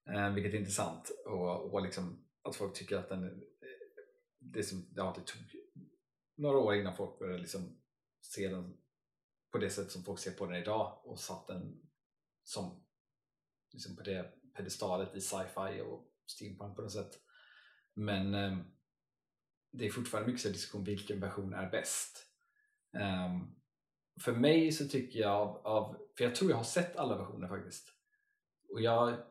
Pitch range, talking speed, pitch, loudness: 100-145 Hz, 160 wpm, 105 Hz, -38 LUFS